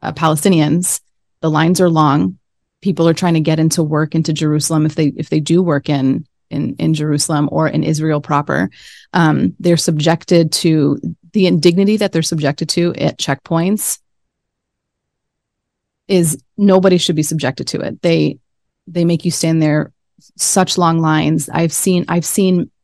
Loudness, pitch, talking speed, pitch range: -15 LUFS, 165 Hz, 160 wpm, 155-175 Hz